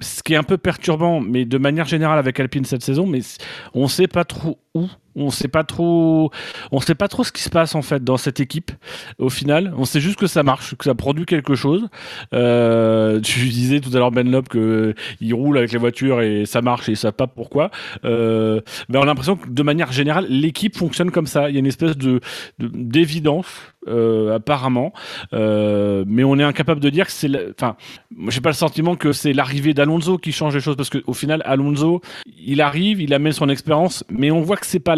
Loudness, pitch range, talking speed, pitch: -18 LUFS, 125-160 Hz, 225 wpm, 145 Hz